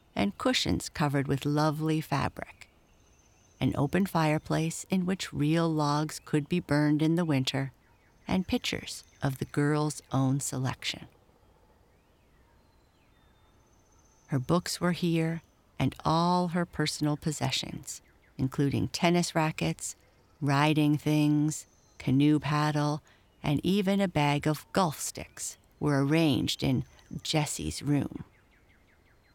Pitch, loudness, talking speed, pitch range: 145 Hz, -29 LUFS, 110 wpm, 125-160 Hz